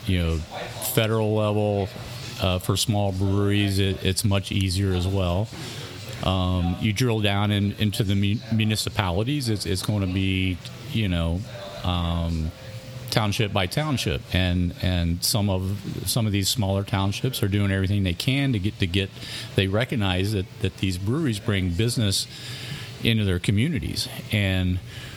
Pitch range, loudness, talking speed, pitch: 95-115 Hz, -24 LUFS, 150 wpm, 100 Hz